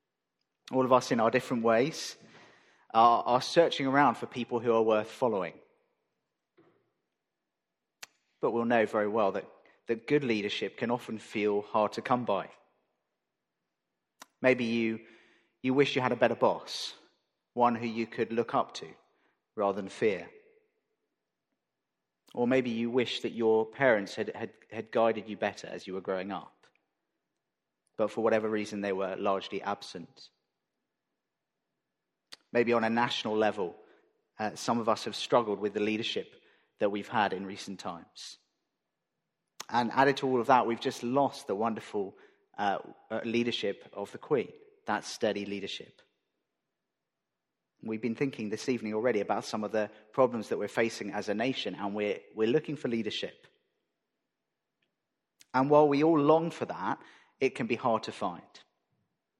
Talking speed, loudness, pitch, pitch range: 155 wpm, -30 LUFS, 115 Hz, 105-130 Hz